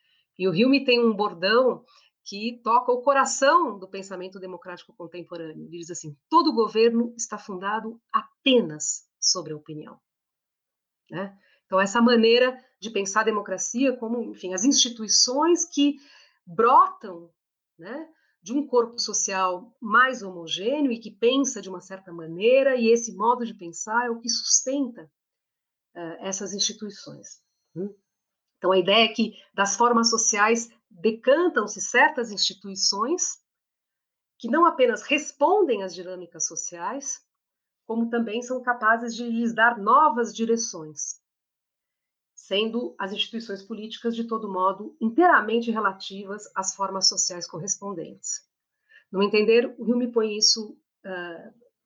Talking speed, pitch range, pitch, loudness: 130 wpm, 190-245 Hz, 220 Hz, -23 LUFS